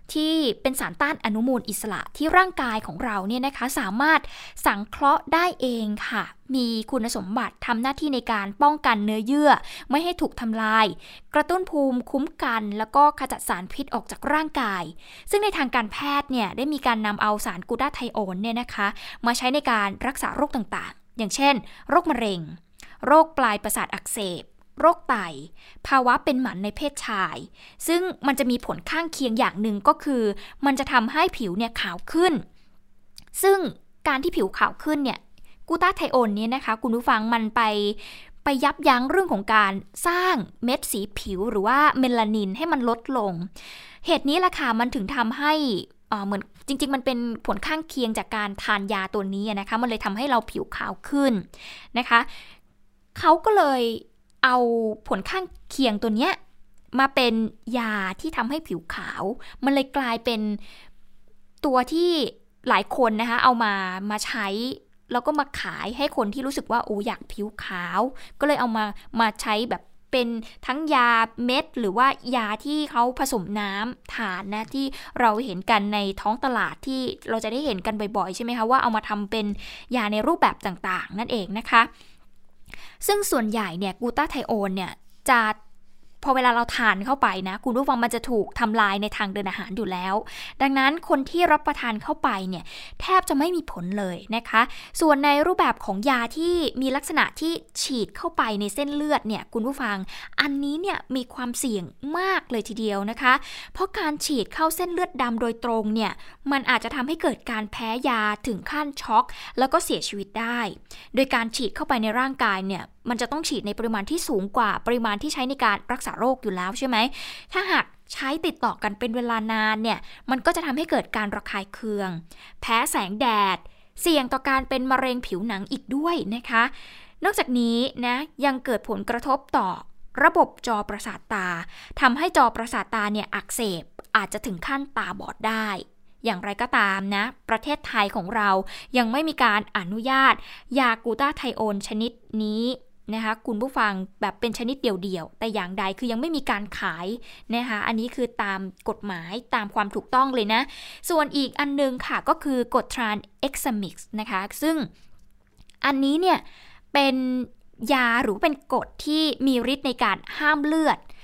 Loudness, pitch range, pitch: -24 LUFS, 215-280 Hz, 240 Hz